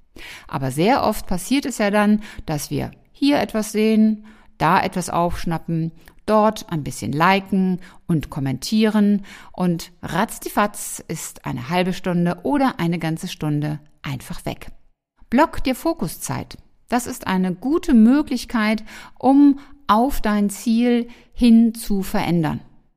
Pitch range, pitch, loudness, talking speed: 170-235 Hz, 205 Hz, -20 LUFS, 125 wpm